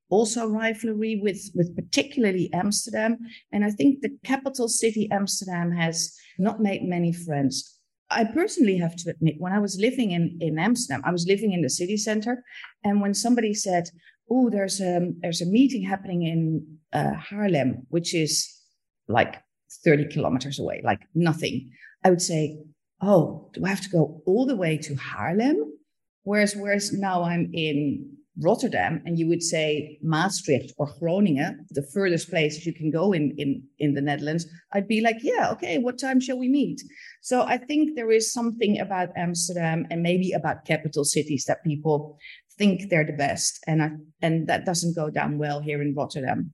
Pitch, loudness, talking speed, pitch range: 175 Hz, -25 LUFS, 175 wpm, 155-210 Hz